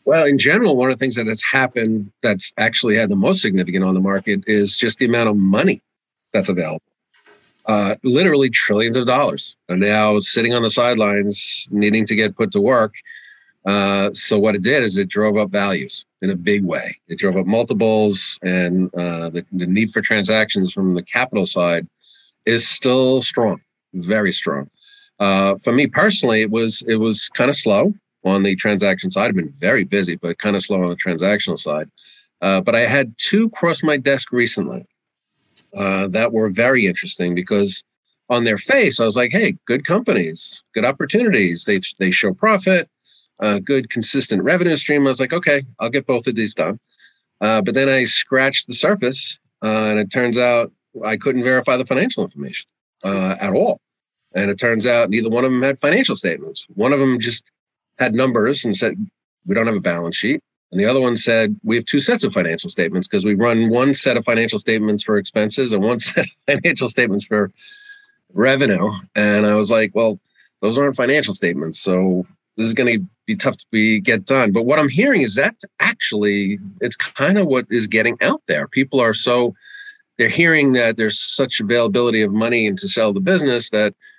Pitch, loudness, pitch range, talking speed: 115 Hz, -17 LUFS, 105-140 Hz, 200 wpm